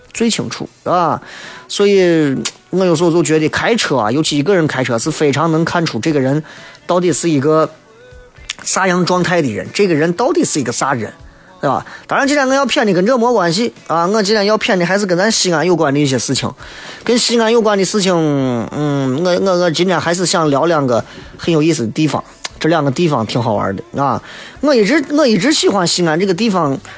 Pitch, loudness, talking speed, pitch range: 170 Hz, -14 LUFS, 310 characters per minute, 145-200 Hz